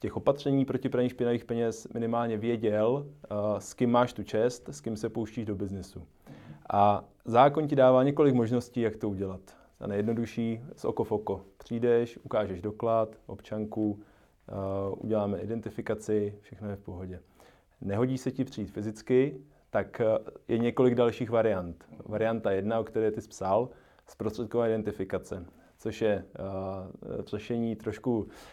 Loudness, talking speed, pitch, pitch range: -30 LUFS, 140 wpm, 110 Hz, 105-120 Hz